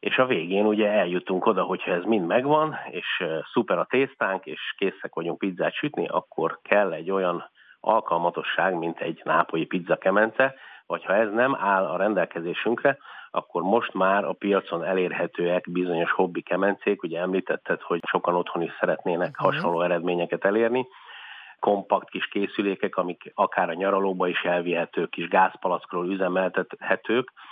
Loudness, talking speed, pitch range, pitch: -25 LUFS, 145 wpm, 85-105 Hz, 90 Hz